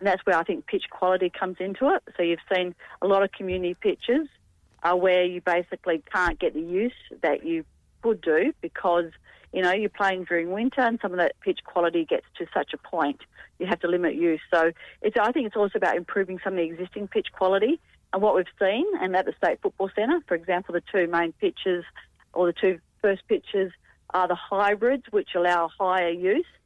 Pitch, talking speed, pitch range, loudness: 185 Hz, 215 wpm, 175-220 Hz, -25 LUFS